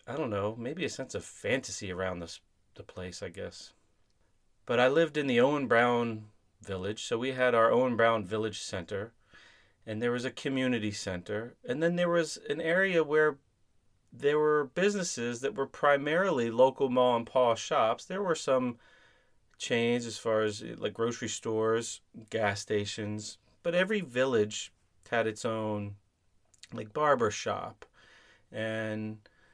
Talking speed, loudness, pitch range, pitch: 155 wpm, -30 LUFS, 105-130 Hz, 115 Hz